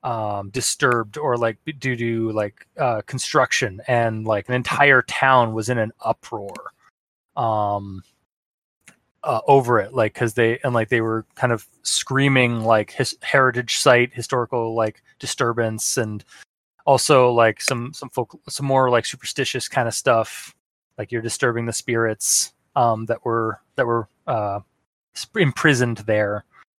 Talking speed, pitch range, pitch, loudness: 150 wpm, 110-125 Hz, 115 Hz, -20 LUFS